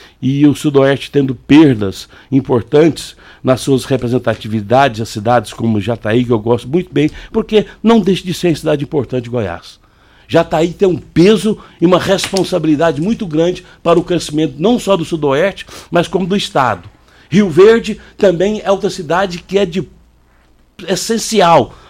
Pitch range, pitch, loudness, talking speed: 125-185 Hz, 160 Hz, -13 LUFS, 160 wpm